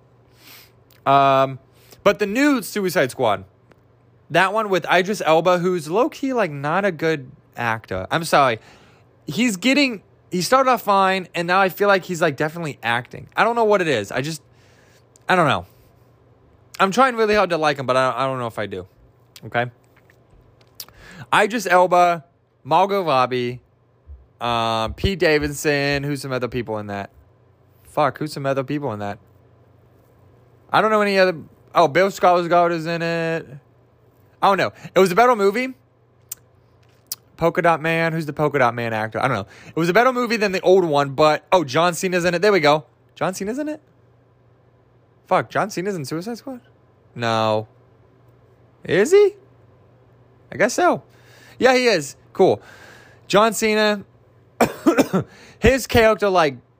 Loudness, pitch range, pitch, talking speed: -19 LUFS, 125-185 Hz, 140 Hz, 165 wpm